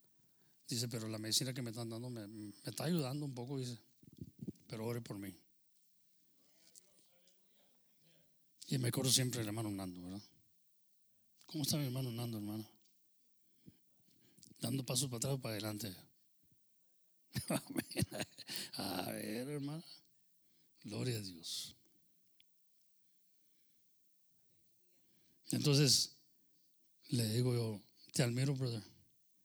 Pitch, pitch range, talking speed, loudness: 125 Hz, 110-145 Hz, 110 wpm, -39 LUFS